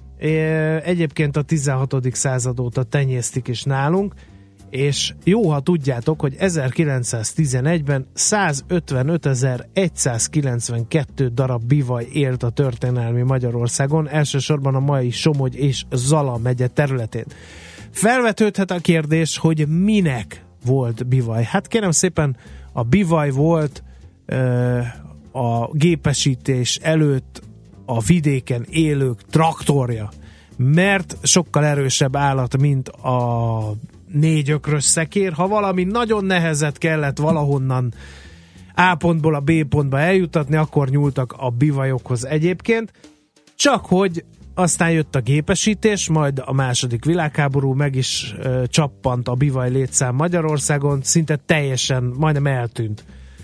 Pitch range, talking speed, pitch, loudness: 125-160 Hz, 110 wpm, 140 Hz, -19 LUFS